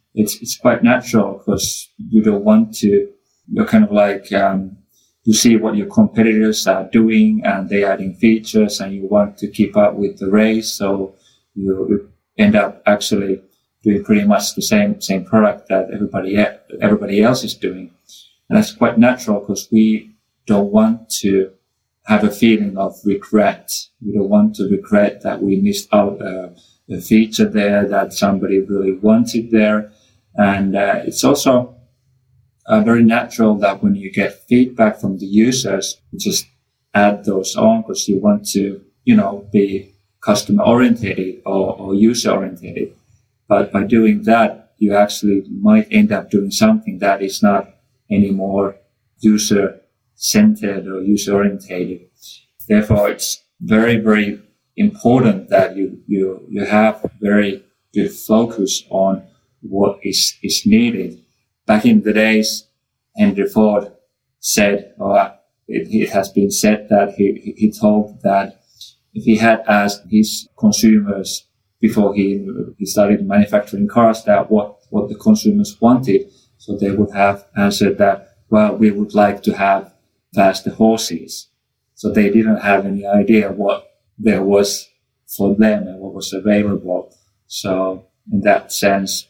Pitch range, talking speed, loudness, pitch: 100-115 Hz, 150 wpm, -15 LUFS, 105 Hz